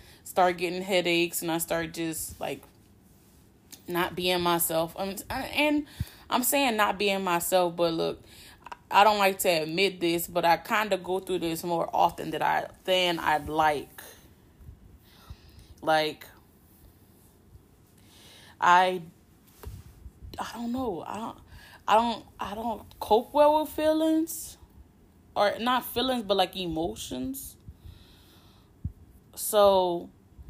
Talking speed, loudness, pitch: 120 wpm, -27 LUFS, 170 Hz